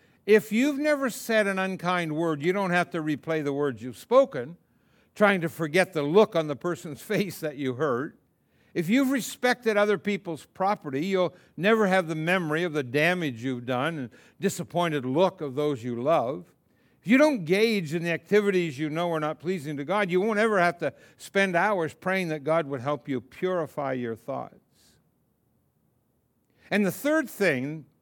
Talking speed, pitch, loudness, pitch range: 180 wpm, 175 Hz, -26 LUFS, 150-200 Hz